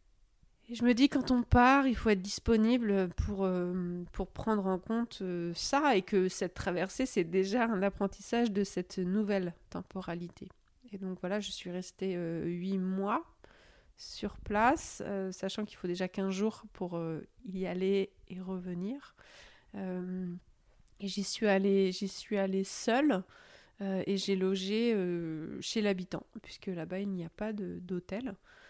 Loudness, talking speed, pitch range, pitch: -33 LUFS, 165 wpm, 185-215 Hz, 195 Hz